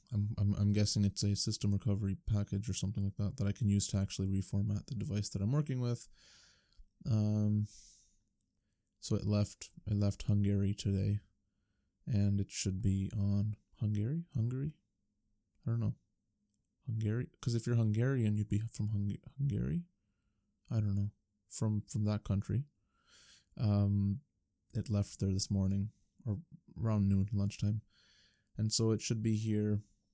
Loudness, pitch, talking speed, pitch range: -35 LUFS, 105 Hz, 155 wpm, 100-110 Hz